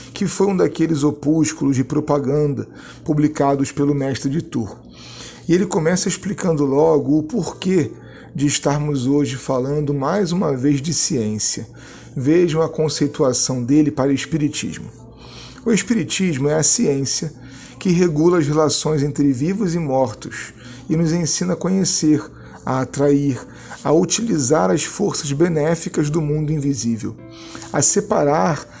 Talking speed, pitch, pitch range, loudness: 135 wpm, 150 Hz, 135-165 Hz, -18 LUFS